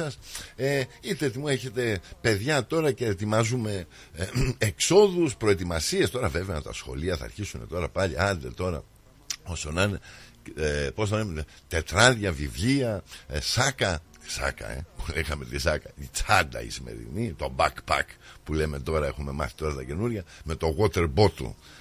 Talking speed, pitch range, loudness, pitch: 150 wpm, 80-115 Hz, -27 LUFS, 95 Hz